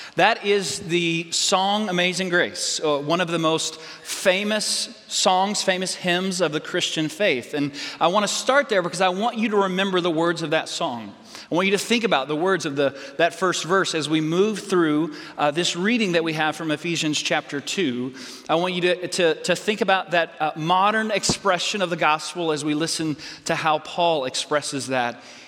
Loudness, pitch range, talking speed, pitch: -22 LUFS, 155-190 Hz, 200 wpm, 175 Hz